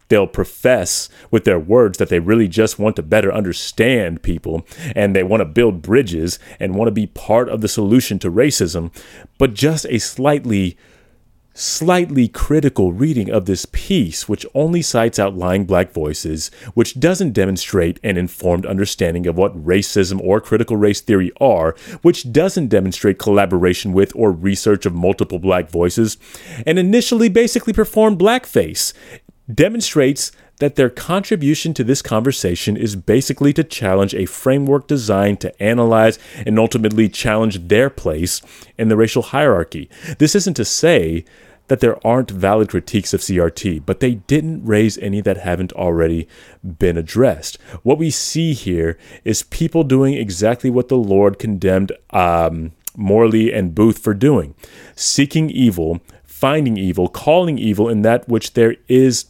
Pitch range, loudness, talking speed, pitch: 95-130 Hz, -16 LUFS, 155 wpm, 110 Hz